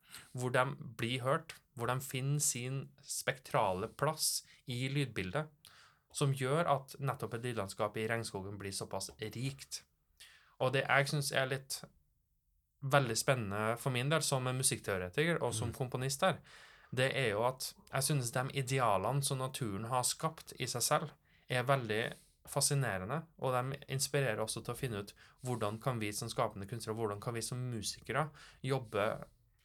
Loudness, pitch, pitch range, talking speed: -36 LUFS, 130 Hz, 115-140 Hz, 160 wpm